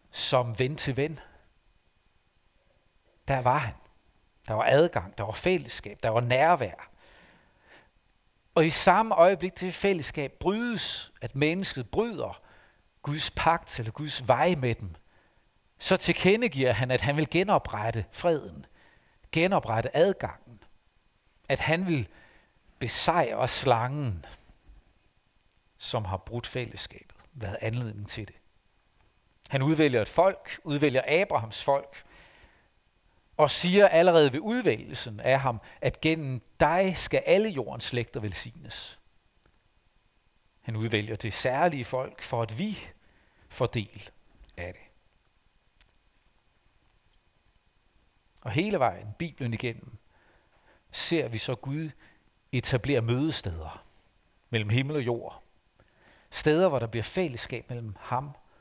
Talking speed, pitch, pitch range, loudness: 115 wpm, 125 Hz, 105-150 Hz, -27 LUFS